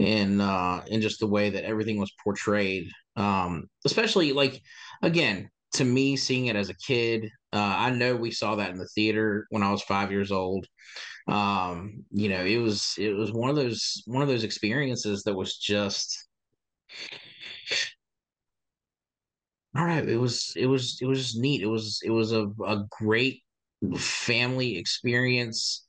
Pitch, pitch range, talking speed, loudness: 110 Hz, 100-120 Hz, 165 wpm, -27 LUFS